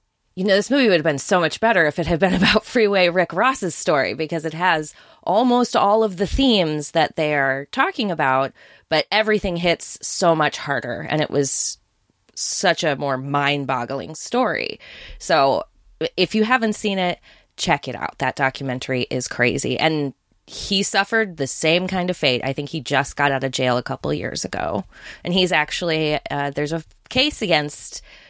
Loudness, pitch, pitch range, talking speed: -20 LUFS, 160 Hz, 140-195 Hz, 185 wpm